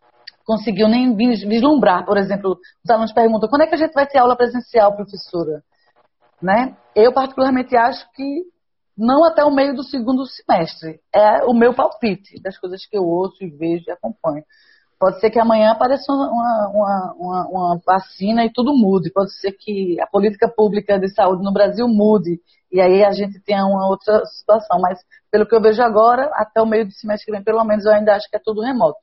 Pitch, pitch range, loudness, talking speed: 215 Hz, 190-240 Hz, -16 LUFS, 200 wpm